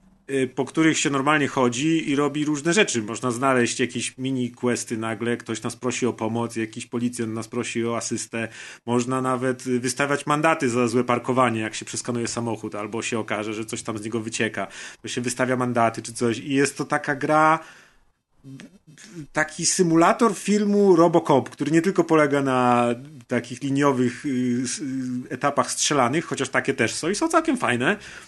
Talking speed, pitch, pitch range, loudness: 165 wpm, 130 Hz, 120-150 Hz, -23 LUFS